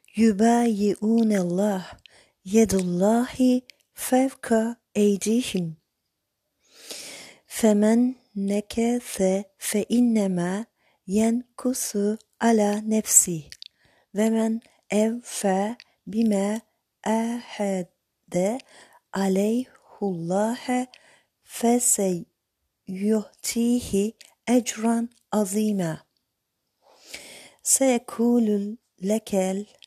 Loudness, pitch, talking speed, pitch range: -24 LUFS, 215 Hz, 50 wpm, 195-235 Hz